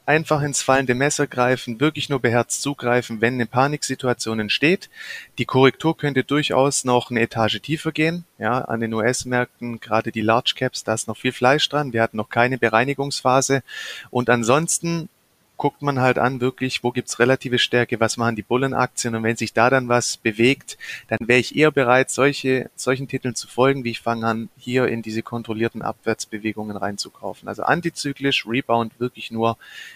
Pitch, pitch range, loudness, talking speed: 125 Hz, 115-135 Hz, -21 LUFS, 180 wpm